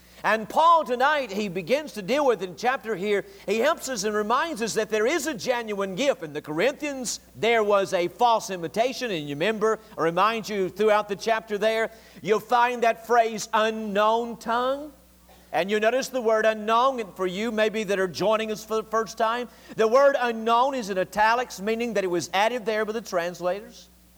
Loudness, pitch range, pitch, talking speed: -24 LUFS, 200-240 Hz, 220 Hz, 200 wpm